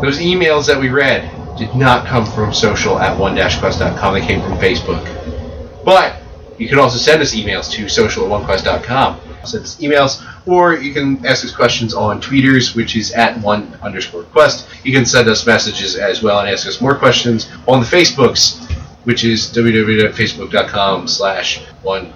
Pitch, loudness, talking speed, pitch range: 120 Hz, -13 LUFS, 180 wpm, 105-135 Hz